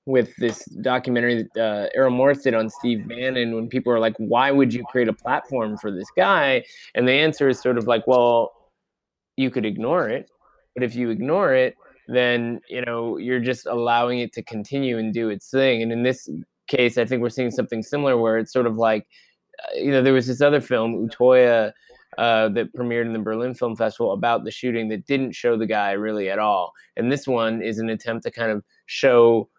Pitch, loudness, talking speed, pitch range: 120 Hz, -21 LUFS, 215 wpm, 115-125 Hz